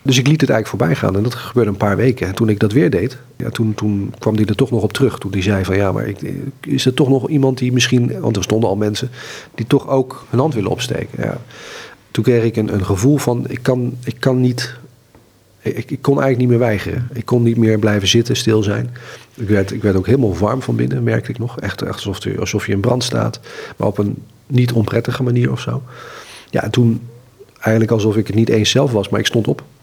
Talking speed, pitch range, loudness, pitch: 255 wpm, 105-130 Hz, -17 LUFS, 115 Hz